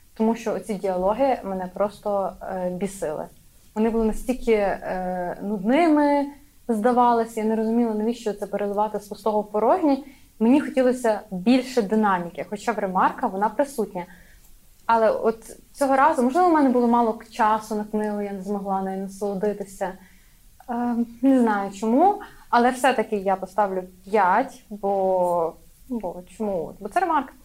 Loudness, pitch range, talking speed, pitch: -23 LUFS, 200-245 Hz, 140 wpm, 215 Hz